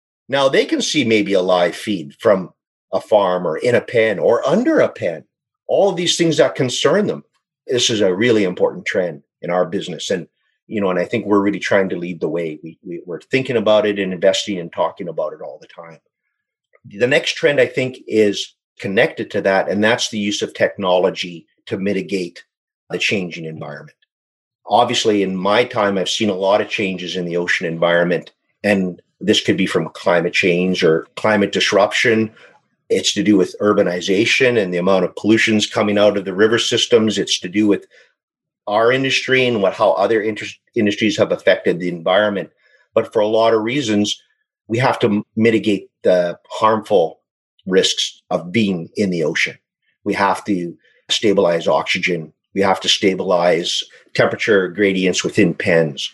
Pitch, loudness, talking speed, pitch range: 105 Hz, -17 LUFS, 185 wpm, 90-115 Hz